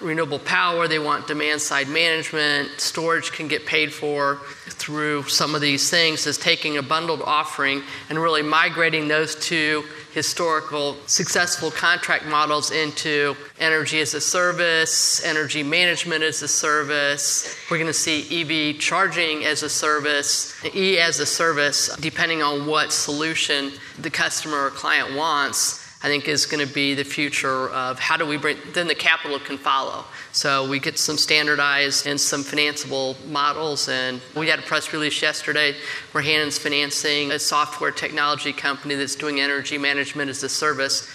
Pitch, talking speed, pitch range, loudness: 150 Hz, 160 wpm, 145-155 Hz, -20 LUFS